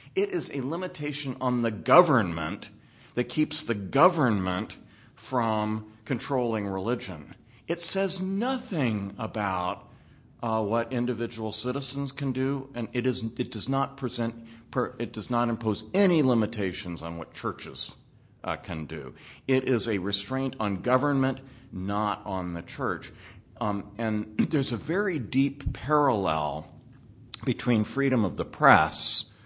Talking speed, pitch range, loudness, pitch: 135 wpm, 105-135 Hz, -27 LUFS, 120 Hz